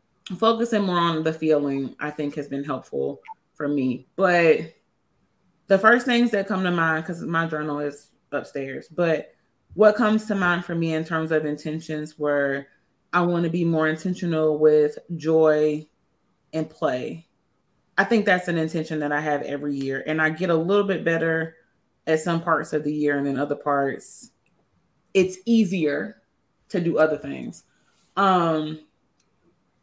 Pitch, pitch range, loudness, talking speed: 160 Hz, 150-175 Hz, -23 LUFS, 165 wpm